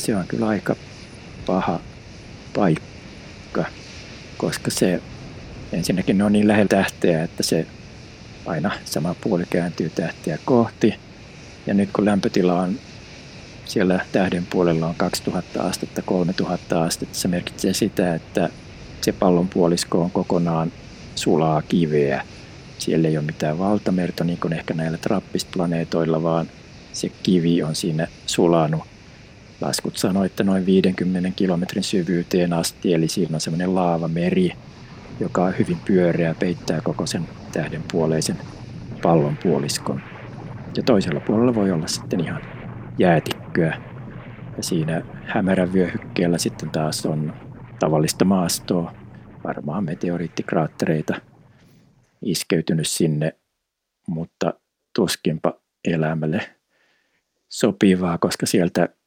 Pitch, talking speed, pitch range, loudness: 90 Hz, 115 wpm, 80-95 Hz, -22 LUFS